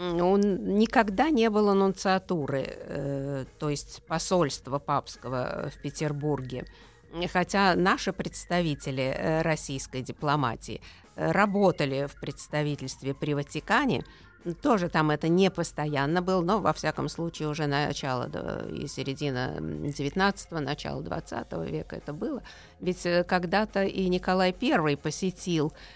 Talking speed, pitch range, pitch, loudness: 115 wpm, 140-185 Hz, 155 Hz, -28 LUFS